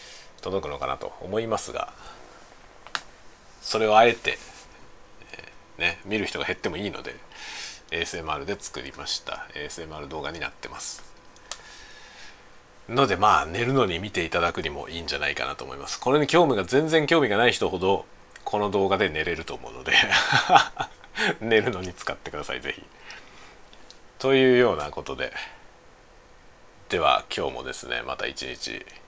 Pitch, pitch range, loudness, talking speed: 110 Hz, 90-130 Hz, -25 LUFS, 305 characters per minute